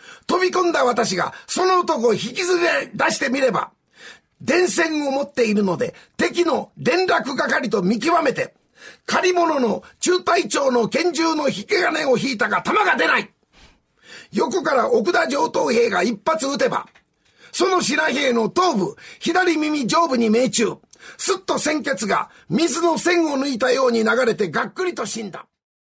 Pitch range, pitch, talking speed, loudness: 245-350 Hz, 305 Hz, 275 characters per minute, -19 LUFS